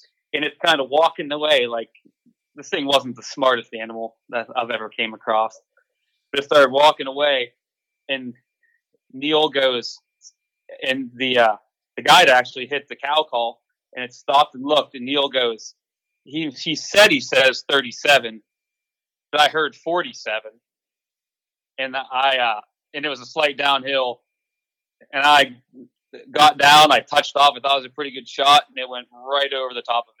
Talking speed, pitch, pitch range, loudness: 175 wpm, 140 Hz, 125-150 Hz, -18 LUFS